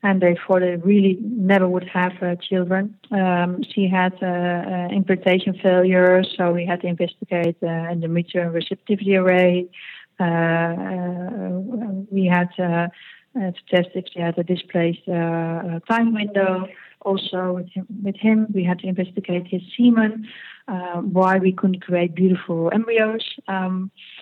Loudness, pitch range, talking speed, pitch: -21 LUFS, 175-195 Hz, 155 wpm, 185 Hz